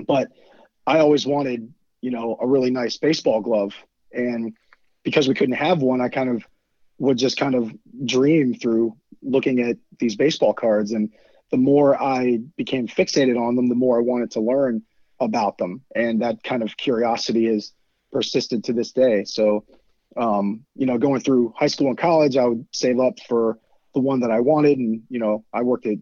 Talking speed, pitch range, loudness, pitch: 190 wpm, 115-135 Hz, -21 LUFS, 125 Hz